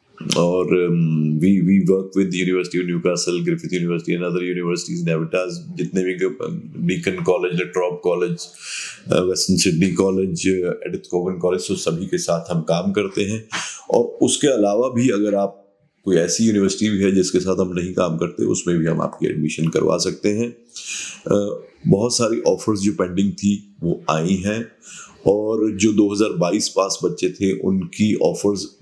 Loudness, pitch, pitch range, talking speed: -20 LUFS, 95 Hz, 90-105 Hz, 150 wpm